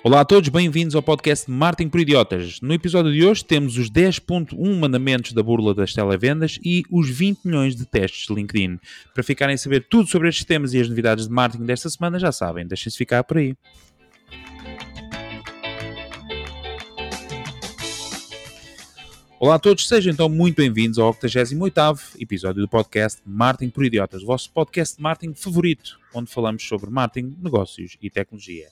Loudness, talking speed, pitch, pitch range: -20 LUFS, 165 wpm, 125 Hz, 110-160 Hz